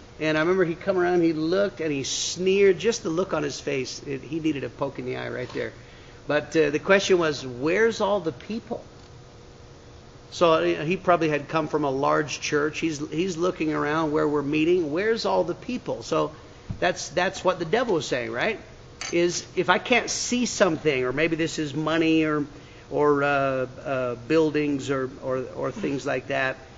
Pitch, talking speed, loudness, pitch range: 155 Hz, 195 wpm, -24 LUFS, 140-180 Hz